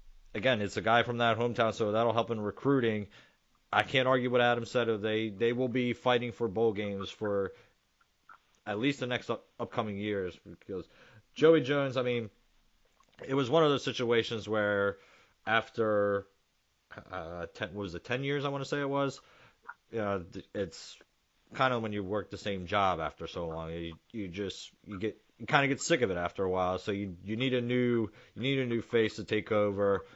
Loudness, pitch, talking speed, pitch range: -31 LUFS, 115 Hz, 205 wpm, 100-125 Hz